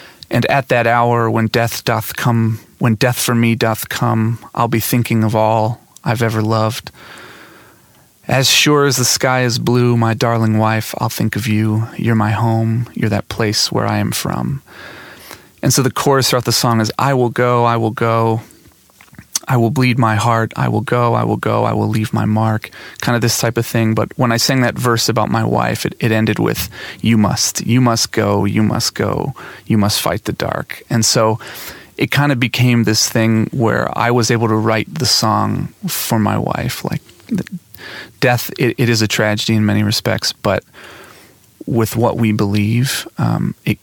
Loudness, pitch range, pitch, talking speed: -15 LUFS, 110-120 Hz, 115 Hz, 195 wpm